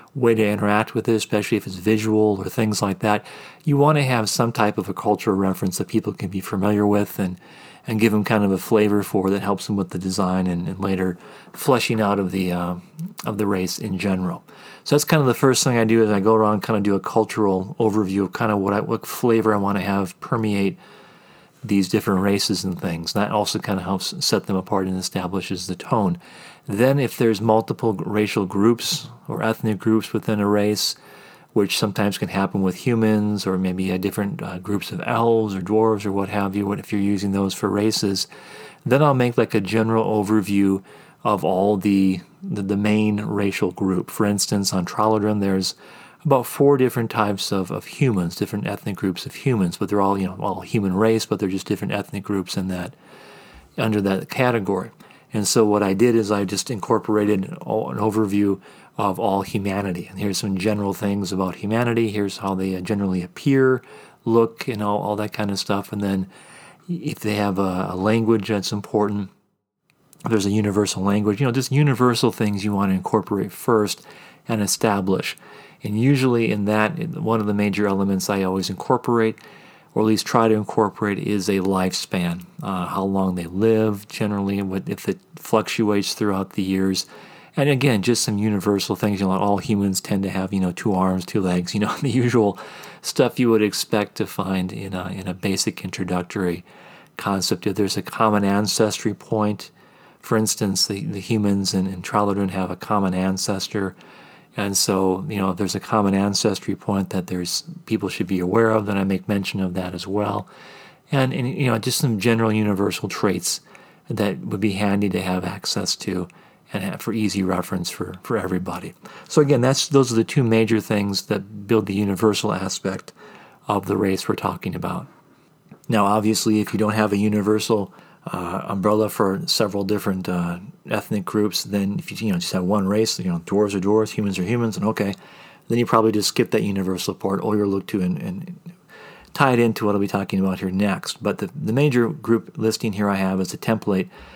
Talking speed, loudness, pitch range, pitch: 200 wpm, -21 LUFS, 95-110 Hz, 105 Hz